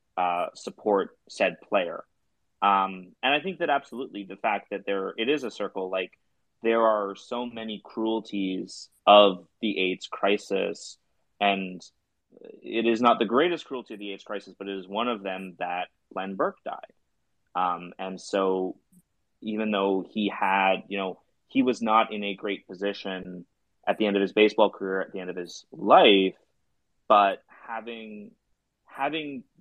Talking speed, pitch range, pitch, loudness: 165 wpm, 95-110 Hz, 100 Hz, -26 LUFS